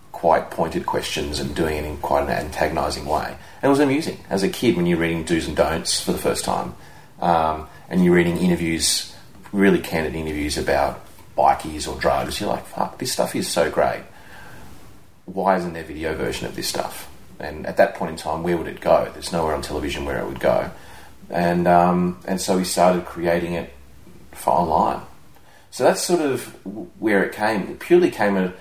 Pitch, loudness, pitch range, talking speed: 85 Hz, -21 LUFS, 80-90 Hz, 205 wpm